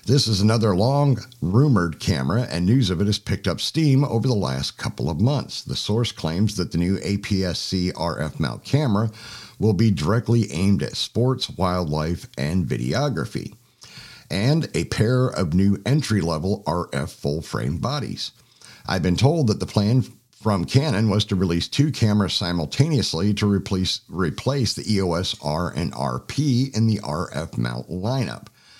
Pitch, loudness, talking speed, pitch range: 100 Hz, -22 LUFS, 165 wpm, 90-115 Hz